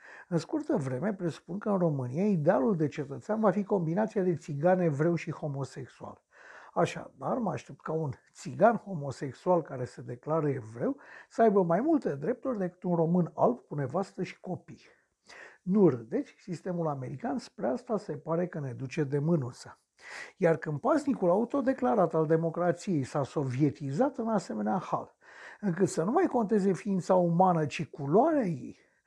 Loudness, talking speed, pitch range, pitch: -30 LUFS, 155 wpm, 150-205 Hz, 175 Hz